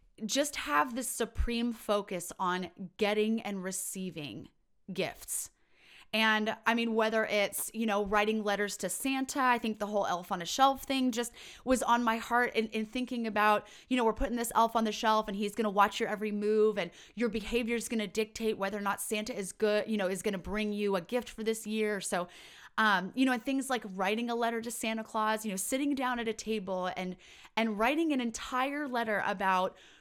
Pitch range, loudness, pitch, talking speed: 200-235 Hz, -32 LUFS, 220 Hz, 210 wpm